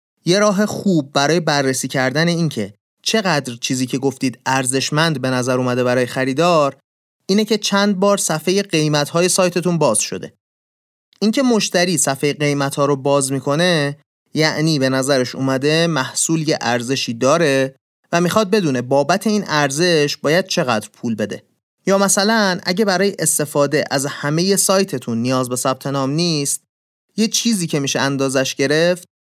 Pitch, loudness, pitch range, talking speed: 150 Hz, -17 LUFS, 135-180 Hz, 145 wpm